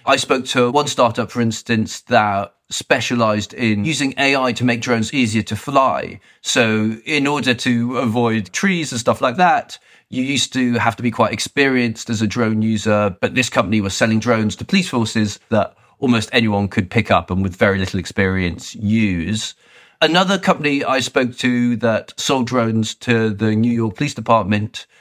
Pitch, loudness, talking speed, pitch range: 115 Hz, -17 LUFS, 180 wpm, 110-130 Hz